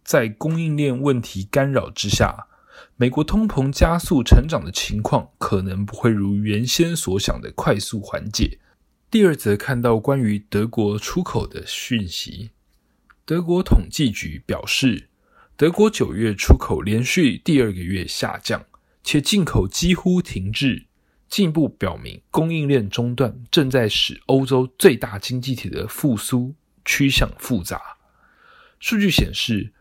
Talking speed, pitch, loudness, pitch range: 215 characters per minute, 125 Hz, -20 LUFS, 105-155 Hz